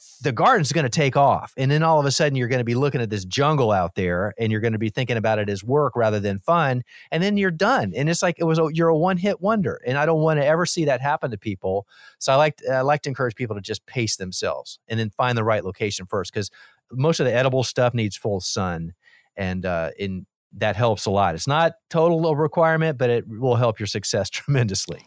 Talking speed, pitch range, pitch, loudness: 255 wpm, 105-155 Hz, 125 Hz, -22 LUFS